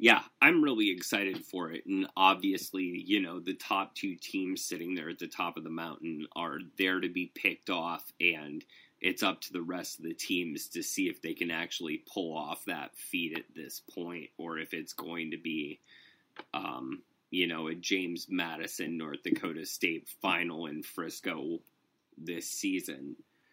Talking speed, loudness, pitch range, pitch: 180 wpm, -33 LUFS, 255-320 Hz, 295 Hz